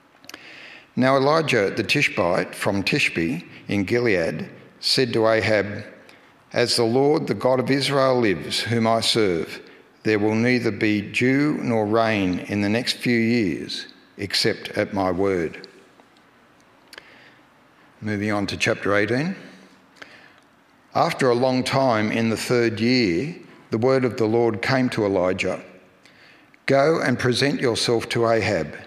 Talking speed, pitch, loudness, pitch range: 135 wpm, 115 Hz, -21 LUFS, 105-130 Hz